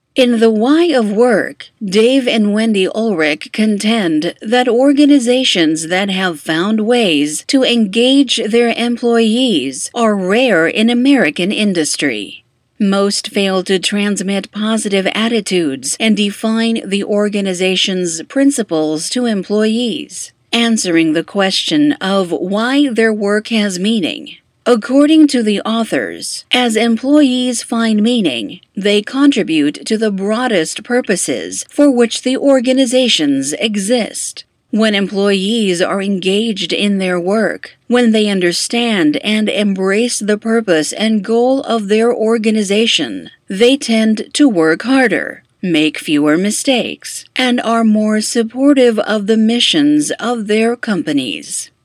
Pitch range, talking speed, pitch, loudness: 200-245 Hz, 120 wpm, 220 Hz, -13 LUFS